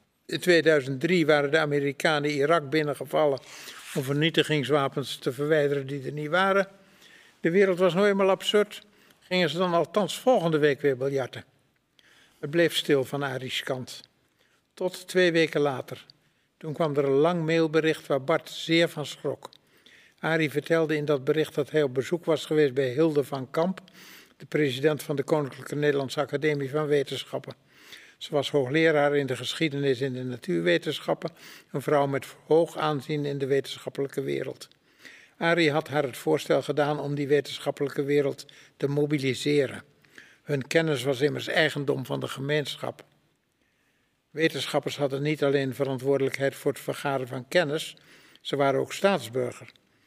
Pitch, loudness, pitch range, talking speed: 150 Hz, -26 LUFS, 140-160 Hz, 150 wpm